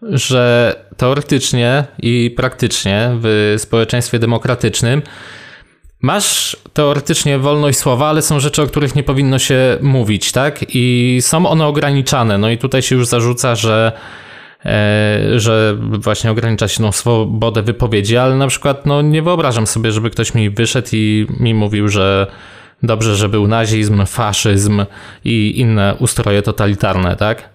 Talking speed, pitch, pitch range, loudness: 145 wpm, 120 Hz, 110-135 Hz, -13 LUFS